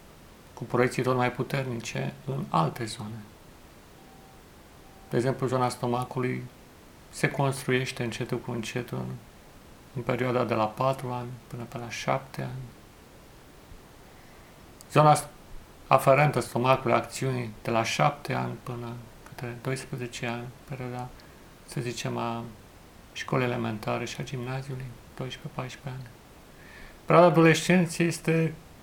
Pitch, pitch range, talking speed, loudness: 125 Hz, 115-130 Hz, 110 wpm, -28 LUFS